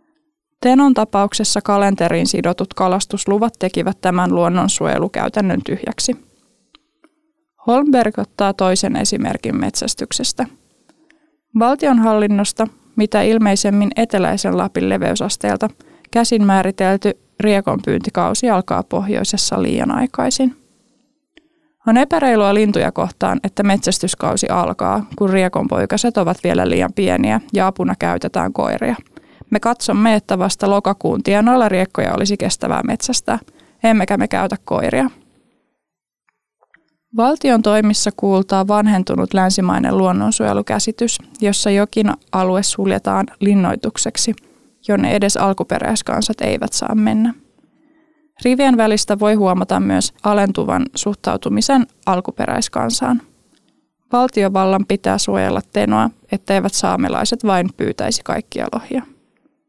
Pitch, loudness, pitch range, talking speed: 215 Hz, -16 LUFS, 195-250 Hz, 95 wpm